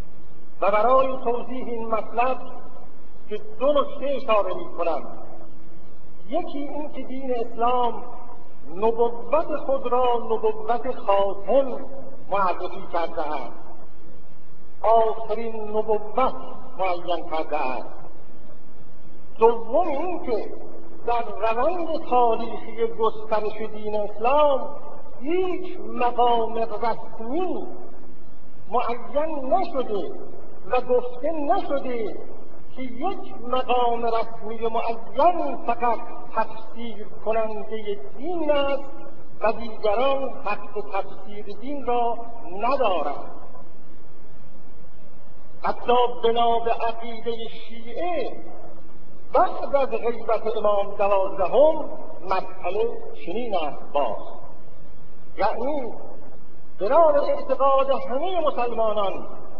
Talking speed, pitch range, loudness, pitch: 80 wpm, 220-275 Hz, -25 LUFS, 235 Hz